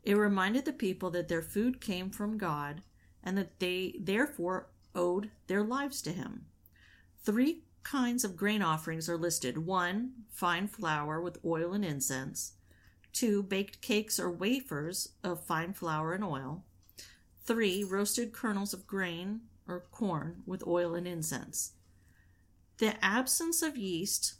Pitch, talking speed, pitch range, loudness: 185 Hz, 145 wpm, 160-210 Hz, -34 LUFS